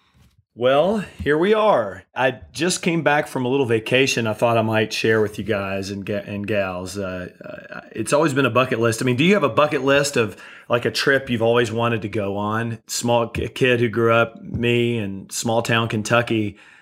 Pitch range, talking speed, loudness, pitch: 110-135 Hz, 220 wpm, -20 LUFS, 115 Hz